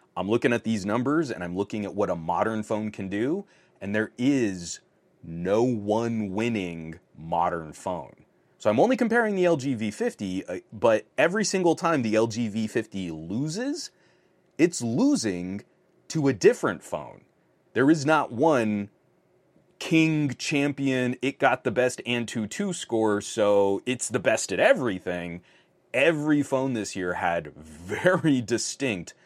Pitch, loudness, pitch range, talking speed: 115 Hz, -26 LUFS, 100-160 Hz, 140 wpm